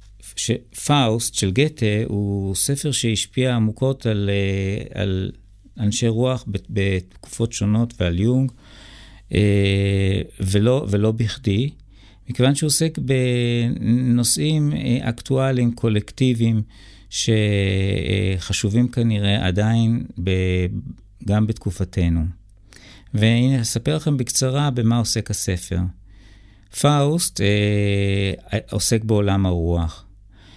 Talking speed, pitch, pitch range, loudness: 80 wpm, 105 Hz, 100-120 Hz, -20 LUFS